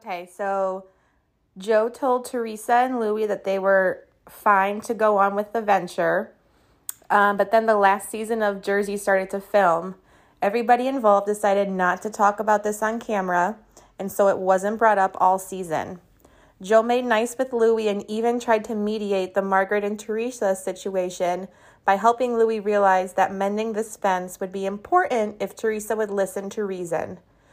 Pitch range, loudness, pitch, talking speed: 190-220 Hz, -22 LUFS, 205 Hz, 170 wpm